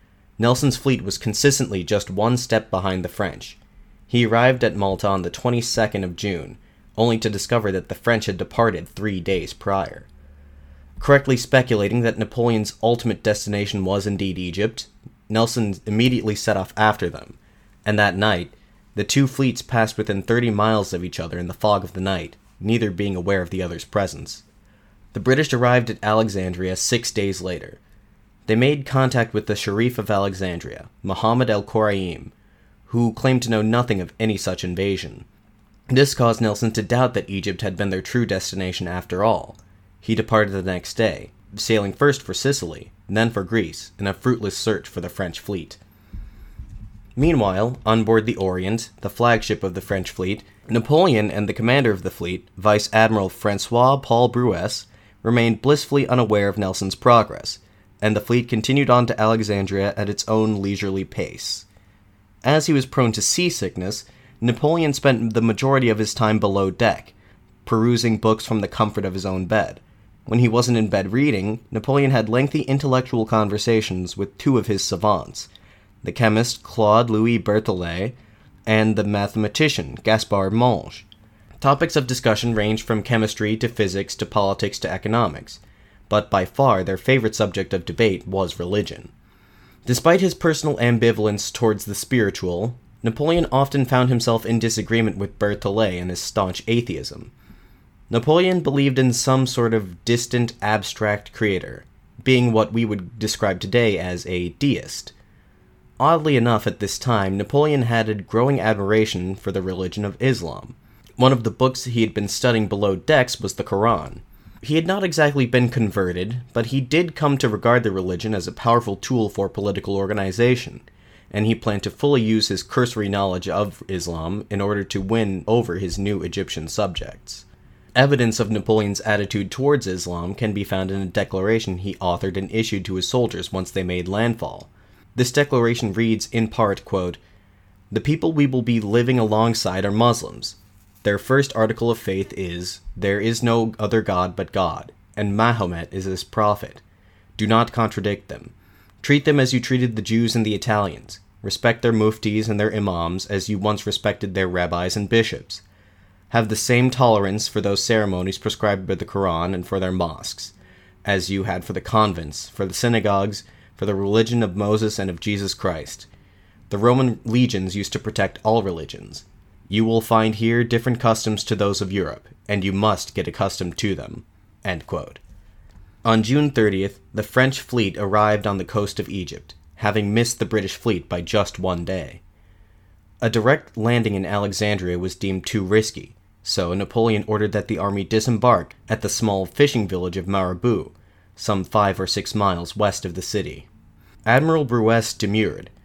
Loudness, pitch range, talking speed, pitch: -21 LUFS, 95-115 Hz, 170 wpm, 105 Hz